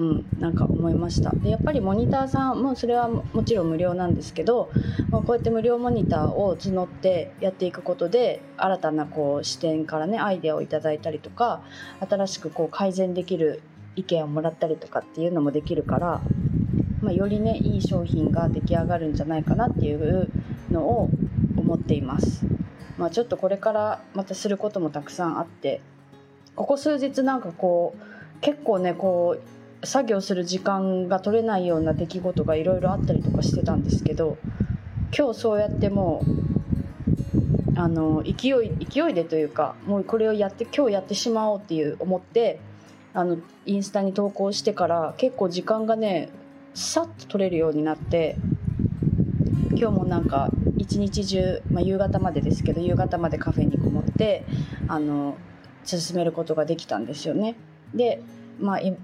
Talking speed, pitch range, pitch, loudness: 355 characters per minute, 155-205 Hz, 180 Hz, -24 LUFS